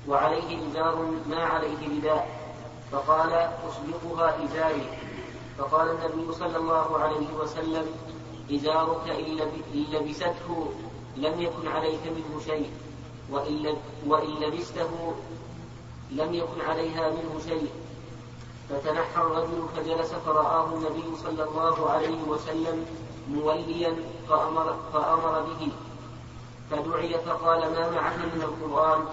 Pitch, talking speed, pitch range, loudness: 160 Hz, 100 wpm, 150-165 Hz, -28 LUFS